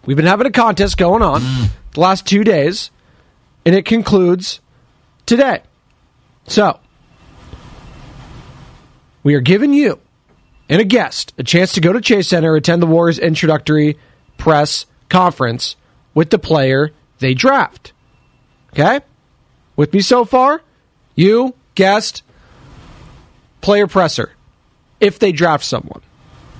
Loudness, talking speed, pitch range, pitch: -14 LUFS, 120 wpm, 150-205 Hz, 175 Hz